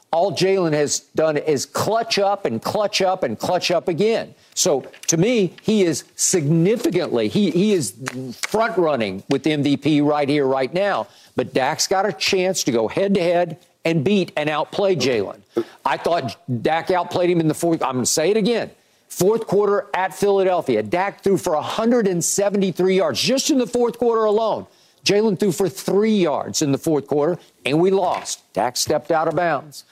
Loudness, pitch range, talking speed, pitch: -20 LUFS, 155-200 Hz, 180 wpm, 180 Hz